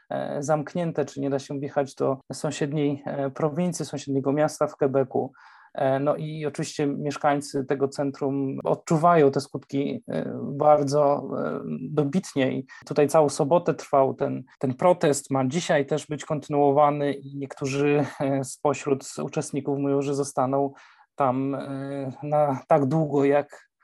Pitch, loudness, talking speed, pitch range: 145 Hz, -25 LUFS, 125 wpm, 140-150 Hz